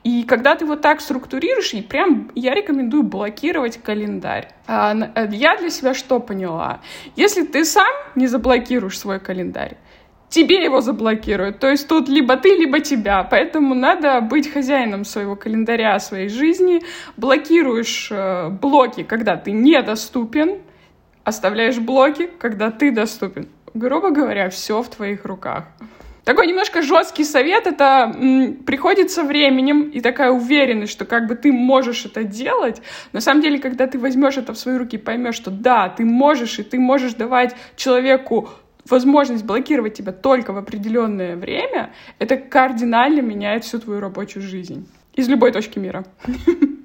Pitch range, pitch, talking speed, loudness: 220-290 Hz, 255 Hz, 145 wpm, -17 LUFS